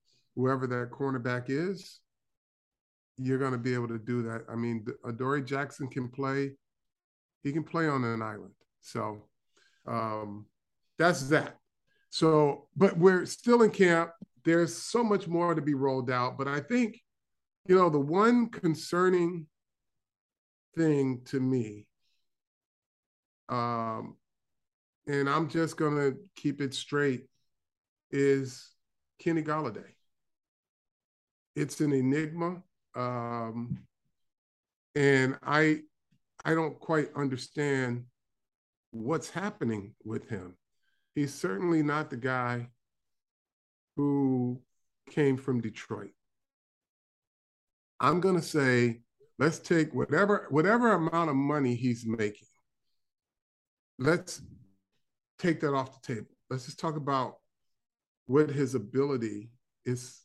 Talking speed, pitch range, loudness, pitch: 115 wpm, 120-160 Hz, -30 LUFS, 140 Hz